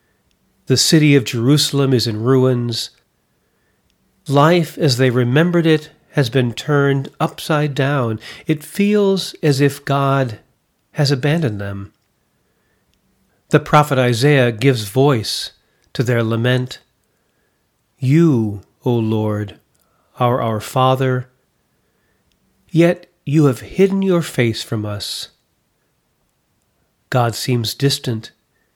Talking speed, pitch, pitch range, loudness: 105 wpm, 130 Hz, 115-150 Hz, -17 LUFS